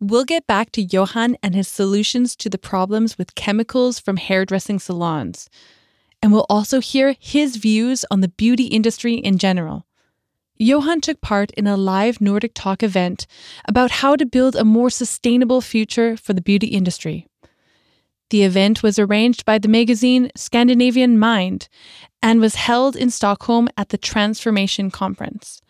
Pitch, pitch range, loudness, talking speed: 220 Hz, 200-245 Hz, -17 LUFS, 155 wpm